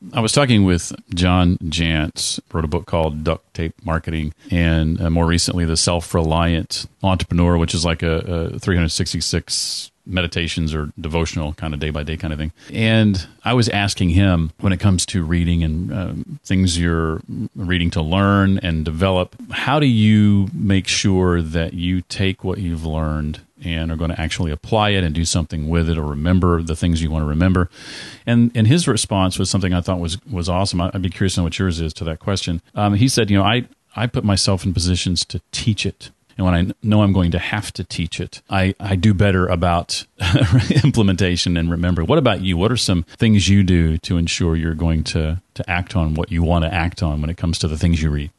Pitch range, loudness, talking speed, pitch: 85-100 Hz, -19 LUFS, 215 wpm, 90 Hz